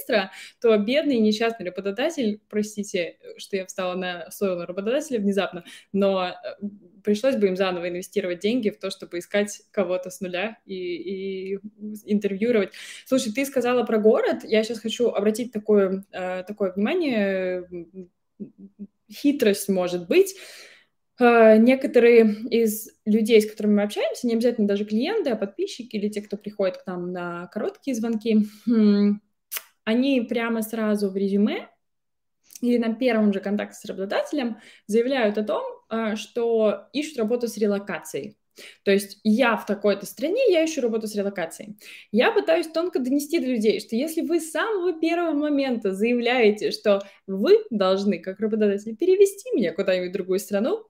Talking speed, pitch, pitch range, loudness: 145 wpm, 215 Hz, 195-240 Hz, -23 LUFS